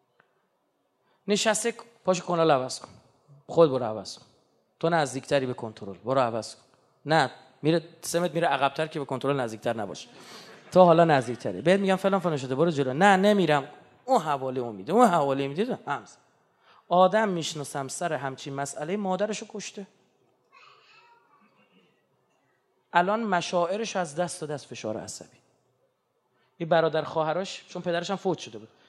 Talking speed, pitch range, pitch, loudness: 145 wpm, 135-190 Hz, 165 Hz, -26 LUFS